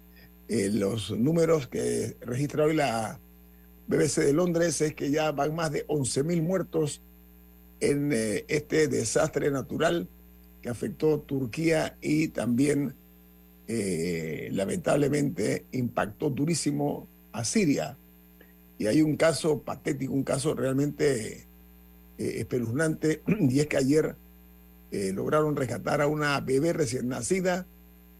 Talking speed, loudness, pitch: 125 wpm, -28 LUFS, 135 Hz